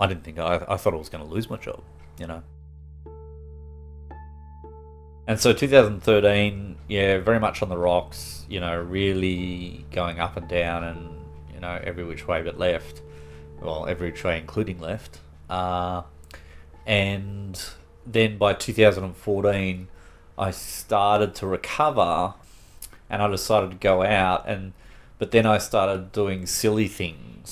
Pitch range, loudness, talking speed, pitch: 75-100 Hz, -24 LUFS, 145 wpm, 90 Hz